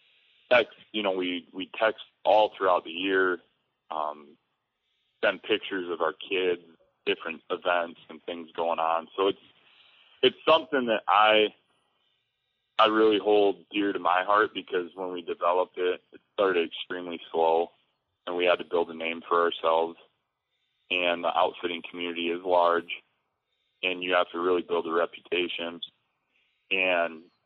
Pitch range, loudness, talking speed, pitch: 85-105 Hz, -27 LUFS, 150 wpm, 90 Hz